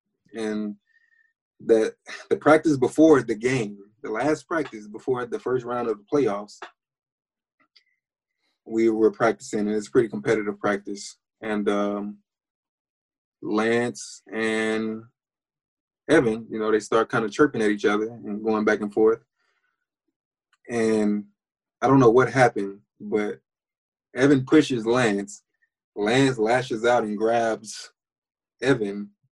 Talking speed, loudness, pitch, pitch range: 125 wpm, -23 LUFS, 110 Hz, 105-135 Hz